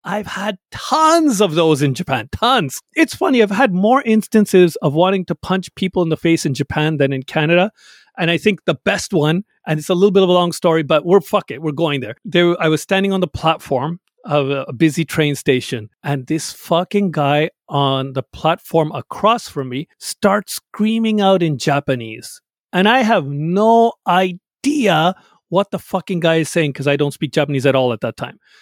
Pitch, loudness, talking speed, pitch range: 170 Hz, -16 LUFS, 205 wpm, 145-195 Hz